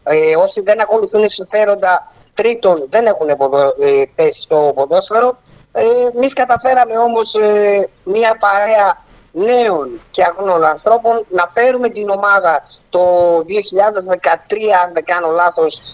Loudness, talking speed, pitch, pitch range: -13 LUFS, 115 wpm, 205 Hz, 175-225 Hz